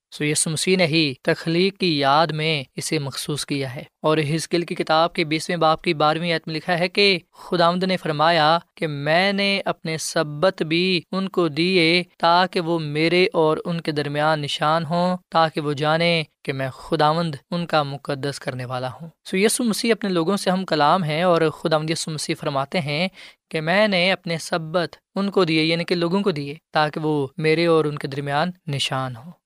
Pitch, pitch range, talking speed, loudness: 165 Hz, 155-180 Hz, 195 wpm, -21 LUFS